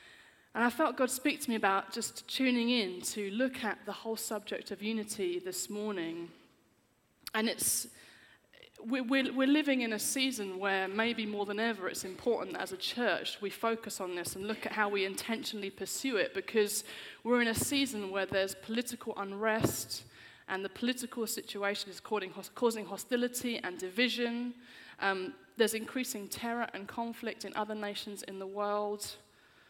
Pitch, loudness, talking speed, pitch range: 220 Hz, -34 LUFS, 165 wpm, 195-240 Hz